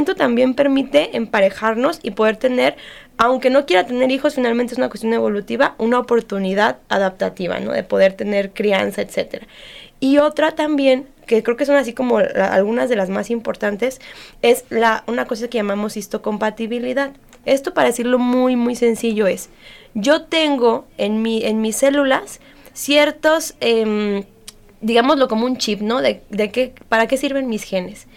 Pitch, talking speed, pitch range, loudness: 240 Hz, 160 wpm, 220-275 Hz, -18 LUFS